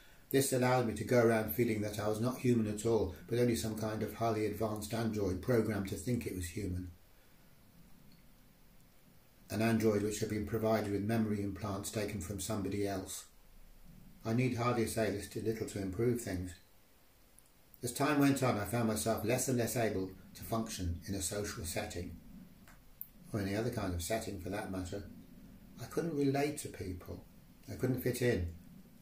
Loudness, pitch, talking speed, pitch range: -35 LUFS, 110 Hz, 180 wpm, 100-115 Hz